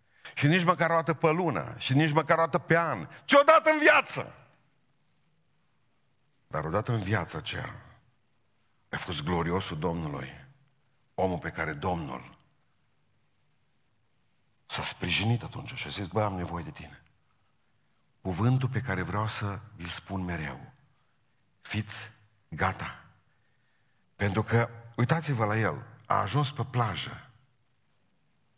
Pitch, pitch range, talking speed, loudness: 120 Hz, 105-145 Hz, 125 wpm, -28 LUFS